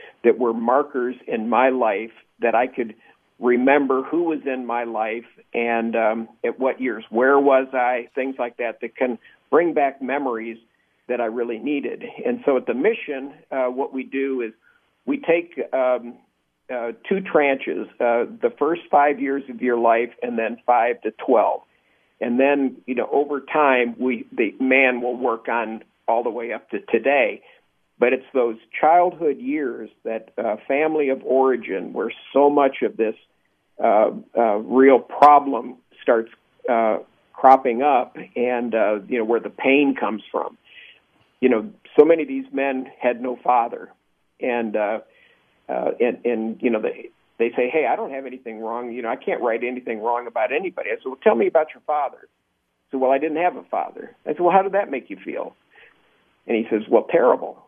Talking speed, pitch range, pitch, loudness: 185 wpm, 120-145 Hz, 130 Hz, -21 LUFS